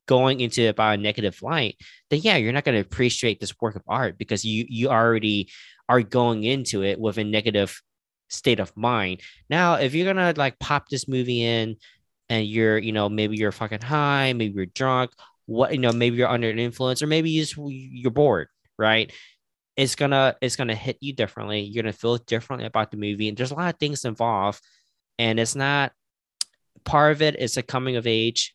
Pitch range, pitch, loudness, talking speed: 110-135 Hz, 120 Hz, -23 LUFS, 210 wpm